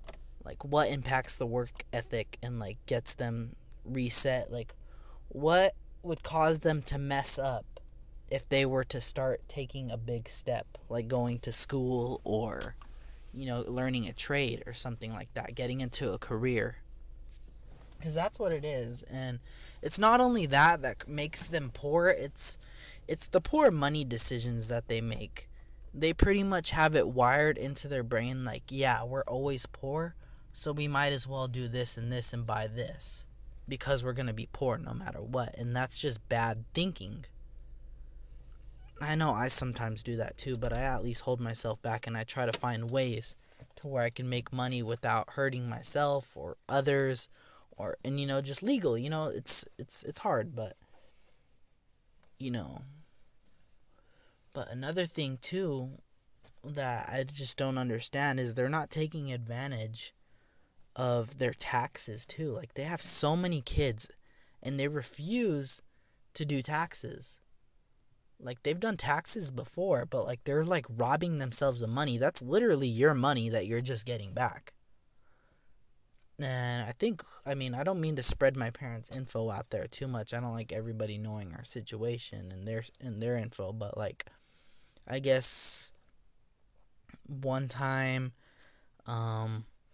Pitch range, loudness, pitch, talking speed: 120-140 Hz, -33 LUFS, 130 Hz, 160 wpm